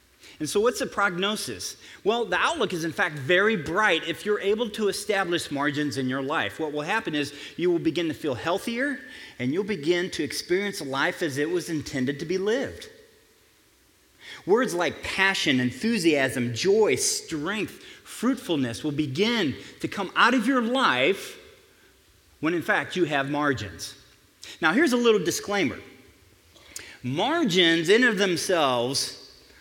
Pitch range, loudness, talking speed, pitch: 145-225 Hz, -25 LUFS, 150 wpm, 180 Hz